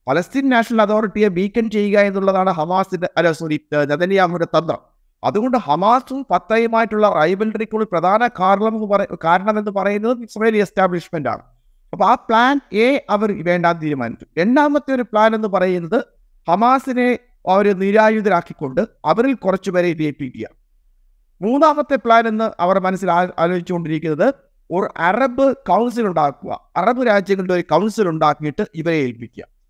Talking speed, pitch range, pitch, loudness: 115 wpm, 170-225 Hz, 200 Hz, -17 LUFS